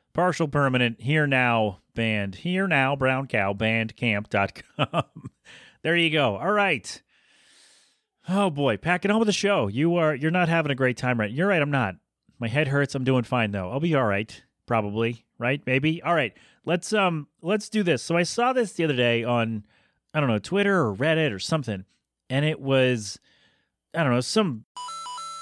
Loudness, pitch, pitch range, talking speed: -24 LUFS, 140 Hz, 120-170 Hz, 185 wpm